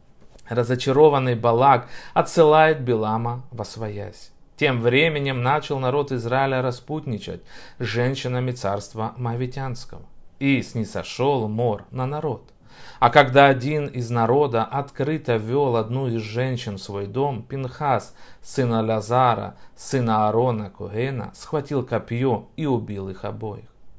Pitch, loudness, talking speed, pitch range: 125 Hz, -22 LUFS, 115 wpm, 110-135 Hz